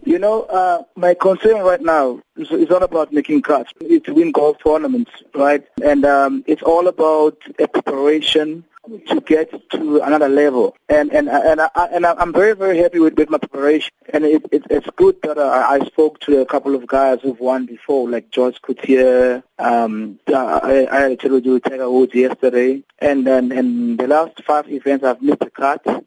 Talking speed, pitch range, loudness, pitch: 200 wpm, 130-175 Hz, -16 LUFS, 150 Hz